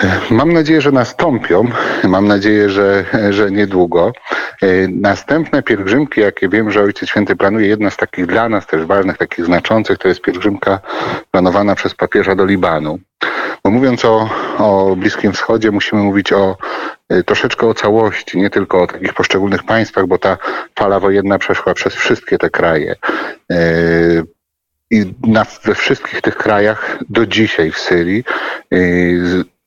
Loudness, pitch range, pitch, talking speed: -13 LUFS, 90-110 Hz, 100 Hz, 145 wpm